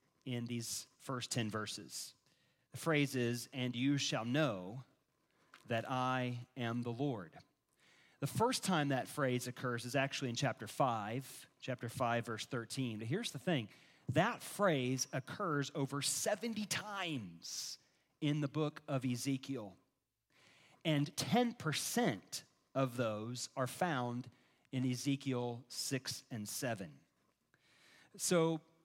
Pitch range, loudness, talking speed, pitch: 120-150 Hz, -39 LUFS, 125 wpm, 135 Hz